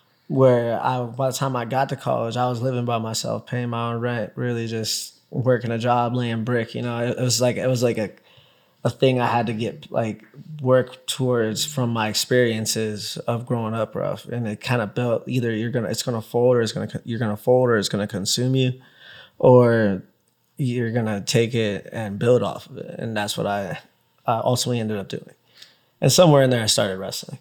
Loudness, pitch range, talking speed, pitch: -22 LUFS, 110-125 Hz, 215 wpm, 120 Hz